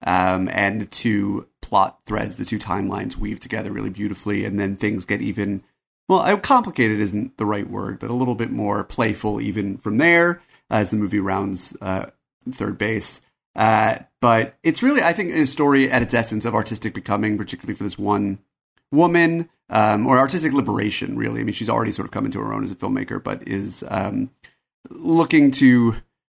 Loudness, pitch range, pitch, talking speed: -21 LUFS, 100-130 Hz, 105 Hz, 185 wpm